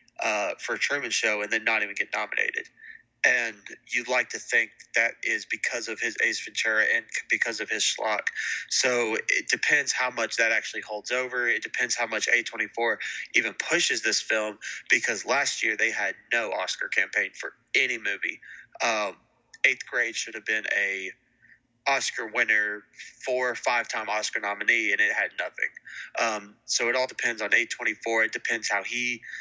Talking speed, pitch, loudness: 175 wpm, 125 Hz, -26 LUFS